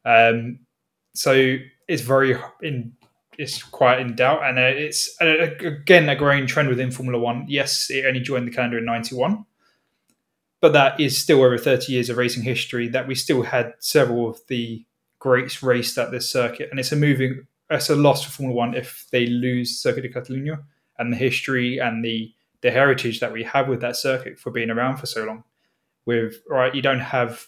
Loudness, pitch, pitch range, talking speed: -21 LUFS, 125 Hz, 120-135 Hz, 195 wpm